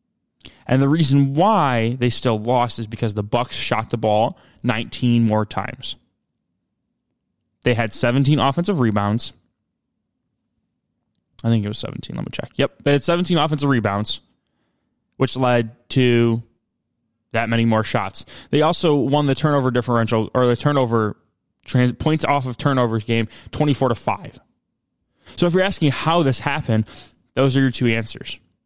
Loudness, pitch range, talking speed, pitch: -20 LUFS, 115-145 Hz, 150 wpm, 125 Hz